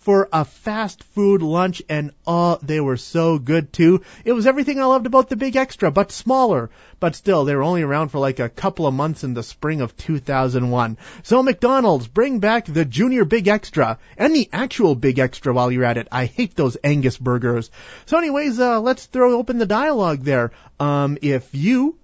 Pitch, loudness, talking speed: 165 Hz, -19 LUFS, 210 wpm